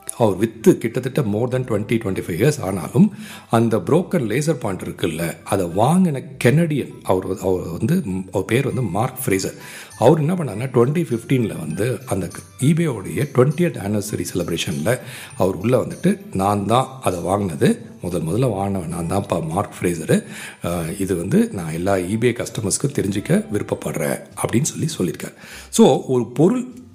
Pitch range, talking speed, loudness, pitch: 95-145 Hz, 150 wpm, -20 LUFS, 120 Hz